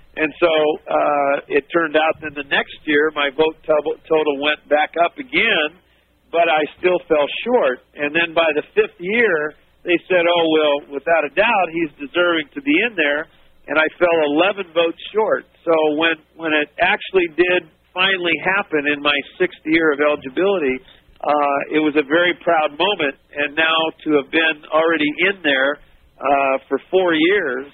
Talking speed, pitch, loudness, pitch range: 175 wpm, 160 Hz, -18 LUFS, 150-175 Hz